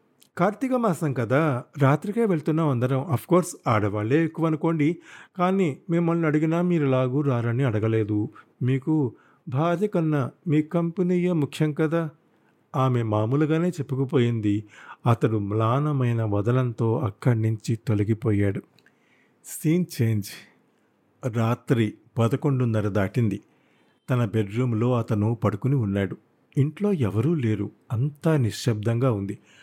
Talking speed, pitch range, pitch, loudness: 100 wpm, 115-160 Hz, 130 Hz, -24 LUFS